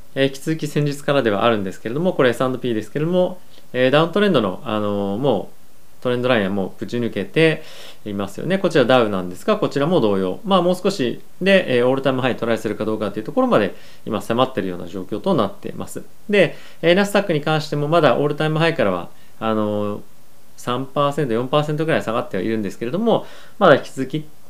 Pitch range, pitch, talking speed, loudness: 110-160 Hz, 130 Hz, 430 characters per minute, -20 LUFS